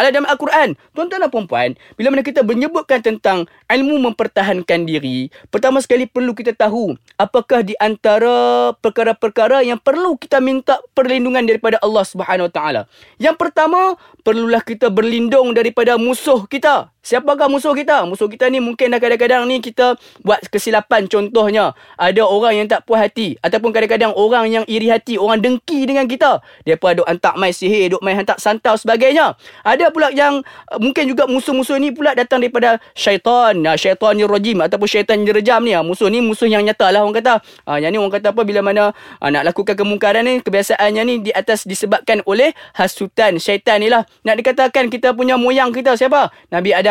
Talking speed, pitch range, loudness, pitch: 175 wpm, 210-260 Hz, -15 LUFS, 230 Hz